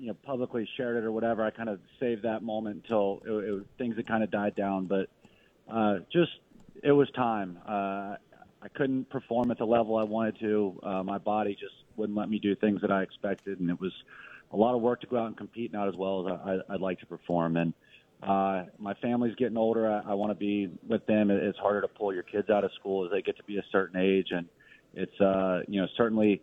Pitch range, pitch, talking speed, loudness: 95-115 Hz, 105 Hz, 245 wpm, -30 LUFS